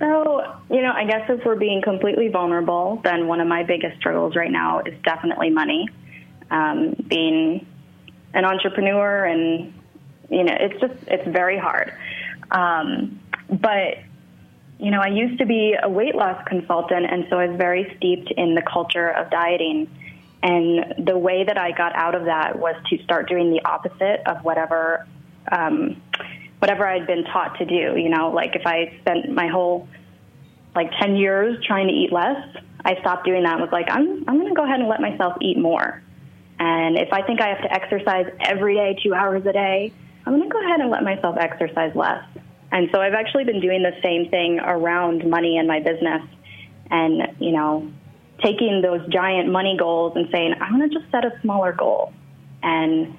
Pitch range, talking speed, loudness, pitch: 170-205 Hz, 190 wpm, -21 LUFS, 180 Hz